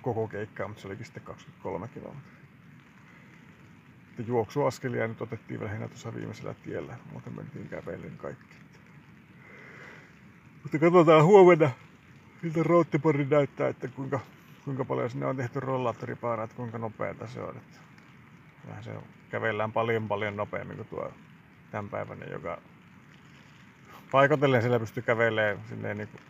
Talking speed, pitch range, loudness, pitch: 120 wpm, 110-150 Hz, -27 LUFS, 125 Hz